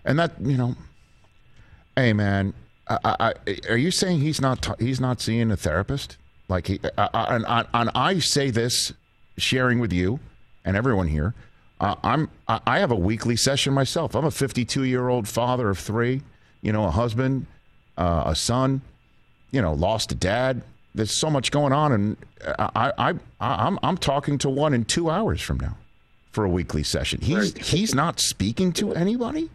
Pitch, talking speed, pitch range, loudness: 125 Hz, 190 wpm, 105-140 Hz, -23 LUFS